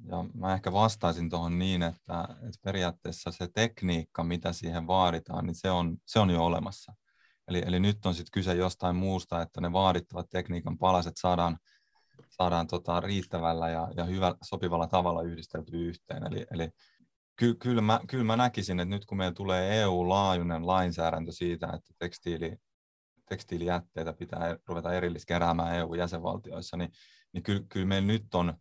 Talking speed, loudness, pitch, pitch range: 160 wpm, -31 LUFS, 90 Hz, 85-95 Hz